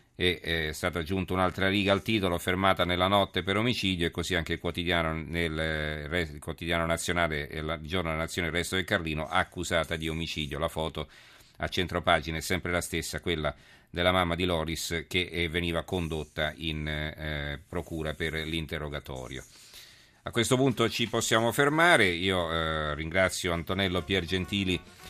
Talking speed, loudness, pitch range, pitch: 160 wpm, -29 LUFS, 80-95 Hz, 85 Hz